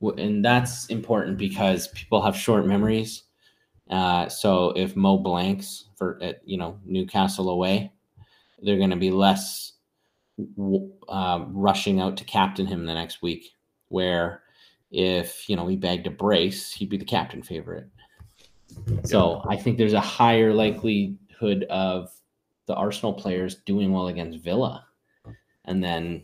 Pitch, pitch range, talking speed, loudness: 95 Hz, 90-100 Hz, 145 wpm, -24 LUFS